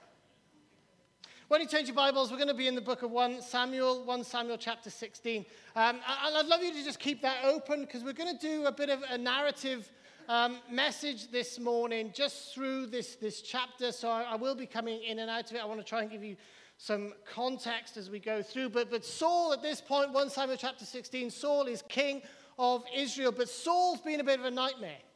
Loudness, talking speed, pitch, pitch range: -33 LUFS, 225 wpm, 250 Hz, 230-275 Hz